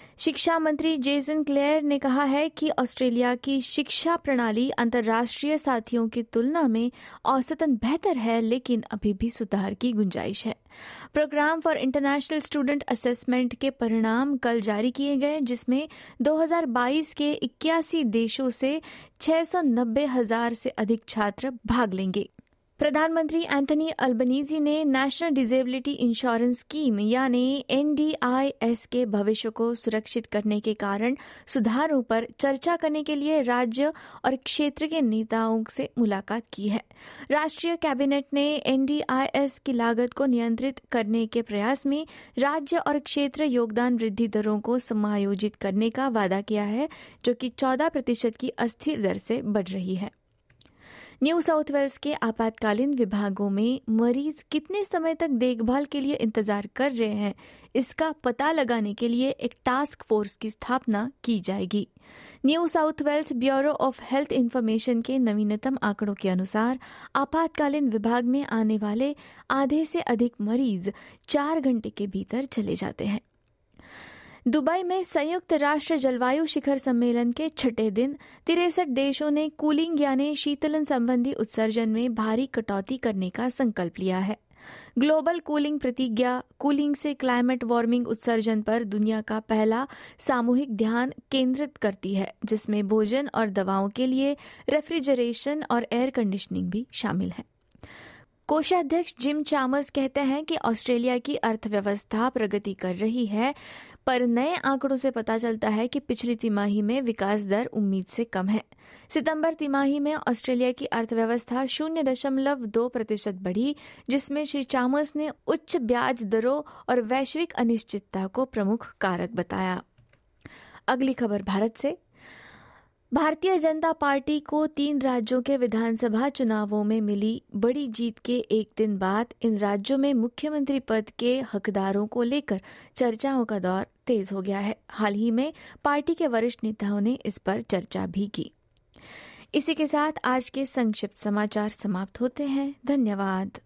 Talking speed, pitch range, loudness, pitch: 145 wpm, 225-285 Hz, -26 LUFS, 250 Hz